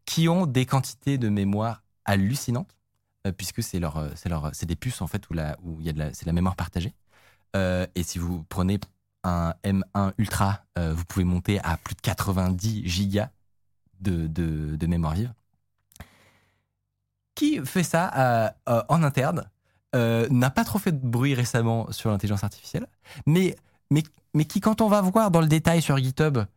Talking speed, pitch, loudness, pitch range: 190 wpm, 105 Hz, -26 LUFS, 90-125 Hz